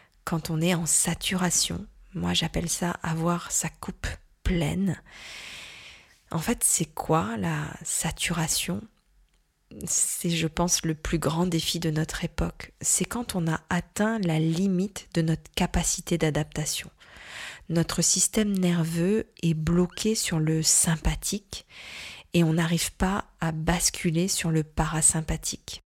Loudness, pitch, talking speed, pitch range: -26 LUFS, 170 Hz, 130 wpm, 160-180 Hz